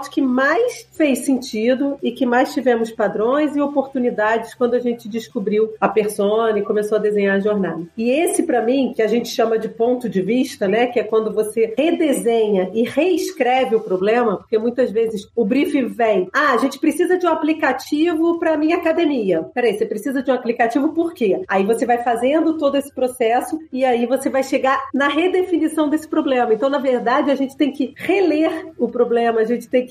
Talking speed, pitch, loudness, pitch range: 200 wpm, 250 Hz, -18 LUFS, 225-285 Hz